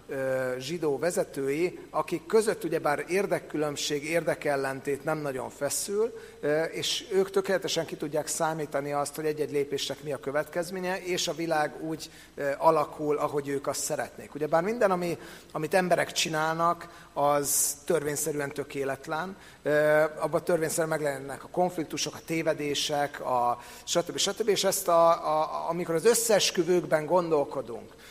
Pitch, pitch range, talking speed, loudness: 155 Hz, 145-170 Hz, 125 wpm, -28 LUFS